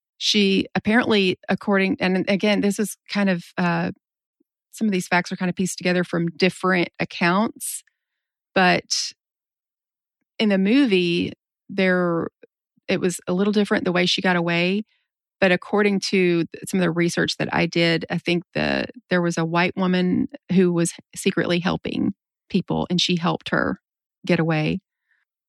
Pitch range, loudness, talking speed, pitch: 175-205 Hz, -21 LUFS, 155 wpm, 185 Hz